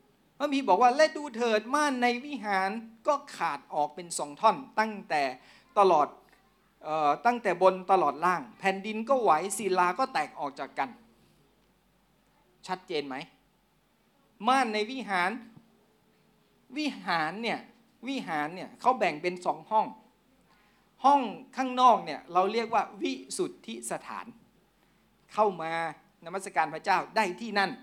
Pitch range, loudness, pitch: 185-255 Hz, -29 LUFS, 215 Hz